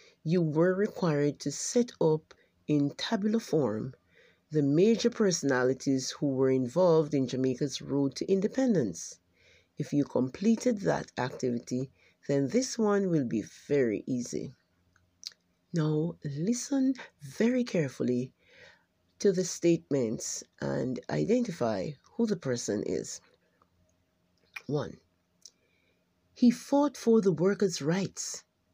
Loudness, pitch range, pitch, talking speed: -29 LUFS, 125-200 Hz, 150 Hz, 110 wpm